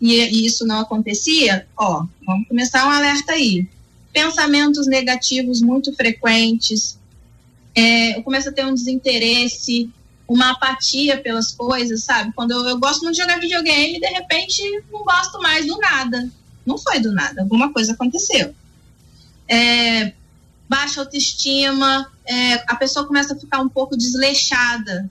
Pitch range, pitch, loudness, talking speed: 230-280 Hz, 255 Hz, -16 LUFS, 145 wpm